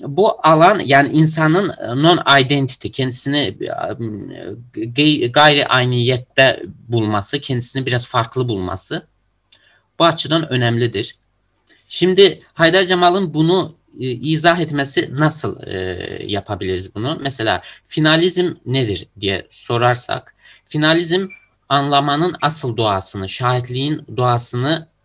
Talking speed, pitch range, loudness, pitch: 90 wpm, 120-155 Hz, -16 LUFS, 135 Hz